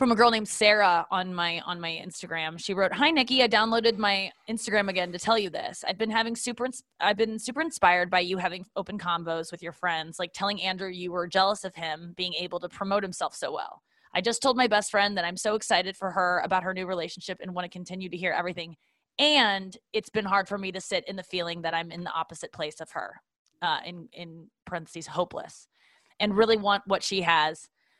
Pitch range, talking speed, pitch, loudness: 175-215 Hz, 230 wpm, 190 Hz, -27 LUFS